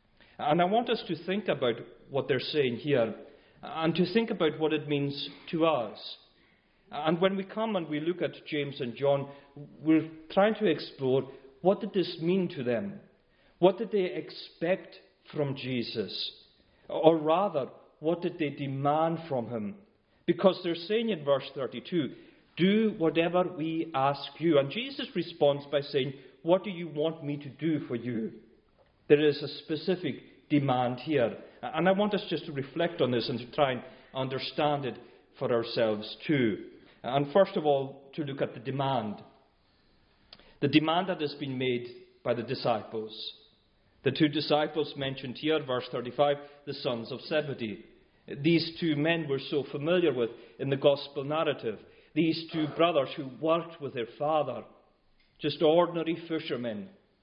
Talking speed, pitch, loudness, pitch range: 165 wpm, 150 Hz, -30 LUFS, 135-170 Hz